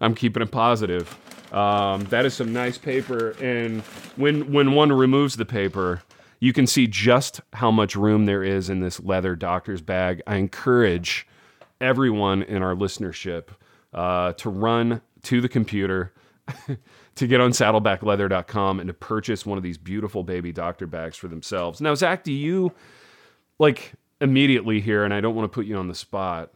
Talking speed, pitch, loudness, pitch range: 170 wpm, 110 Hz, -22 LUFS, 95-125 Hz